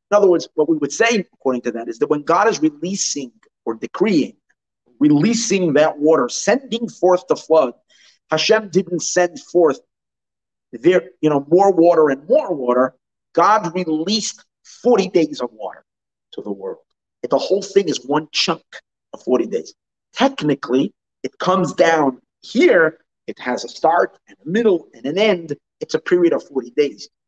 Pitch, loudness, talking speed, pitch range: 175 Hz, -18 LUFS, 170 wpm, 150-210 Hz